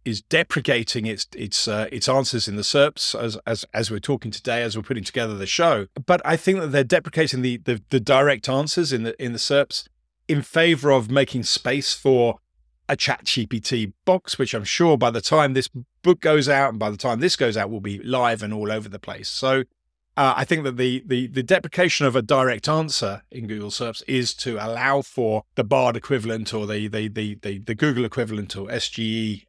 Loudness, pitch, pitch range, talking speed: -22 LUFS, 125 Hz, 110-140 Hz, 215 wpm